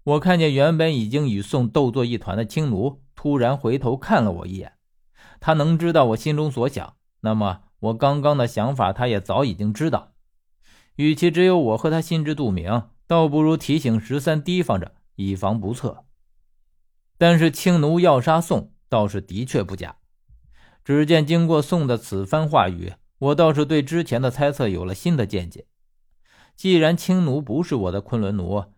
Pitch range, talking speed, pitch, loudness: 105-155 Hz, 255 characters per minute, 135 Hz, -21 LUFS